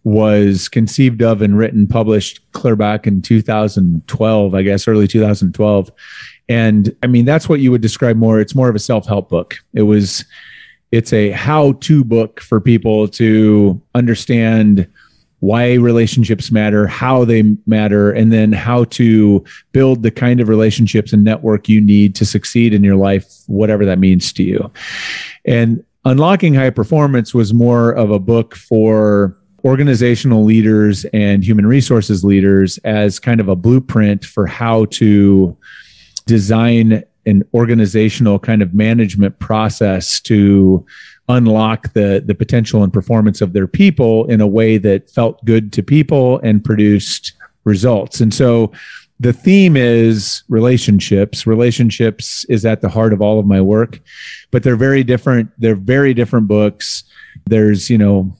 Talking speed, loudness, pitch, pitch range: 155 wpm, -12 LUFS, 110 Hz, 105-120 Hz